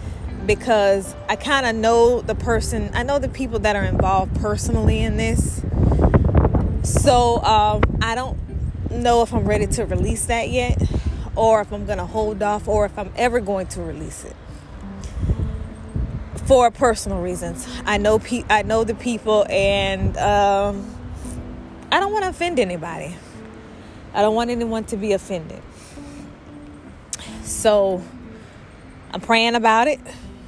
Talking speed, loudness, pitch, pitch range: 145 wpm, -20 LUFS, 210 Hz, 165-230 Hz